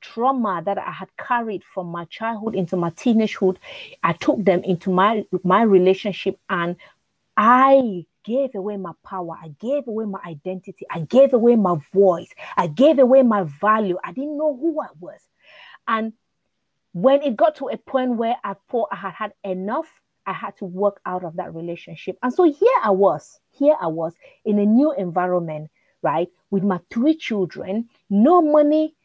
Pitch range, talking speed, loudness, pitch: 185-260 Hz, 180 wpm, -20 LUFS, 205 Hz